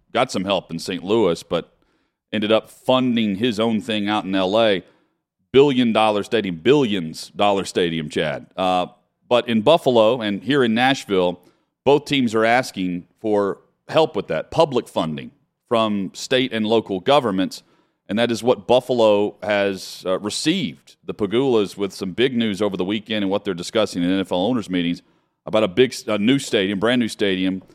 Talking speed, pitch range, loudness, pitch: 175 wpm, 95-115 Hz, -20 LUFS, 105 Hz